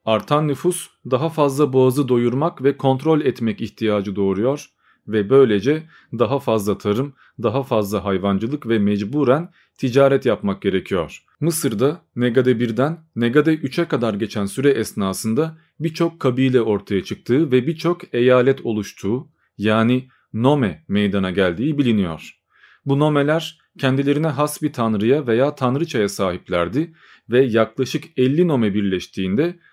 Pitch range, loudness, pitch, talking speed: 110-150 Hz, -19 LUFS, 130 Hz, 120 wpm